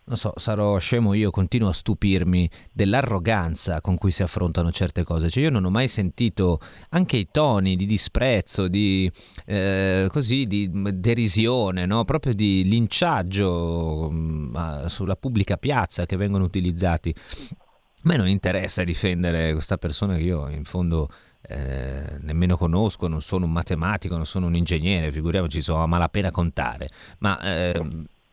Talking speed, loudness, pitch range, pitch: 150 wpm, -23 LUFS, 85-105 Hz, 95 Hz